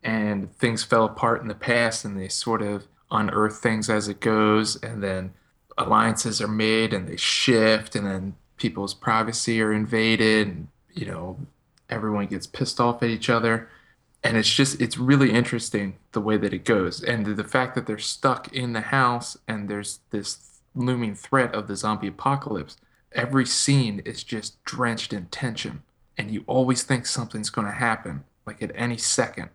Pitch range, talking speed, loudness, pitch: 105-120 Hz, 180 wpm, -24 LUFS, 110 Hz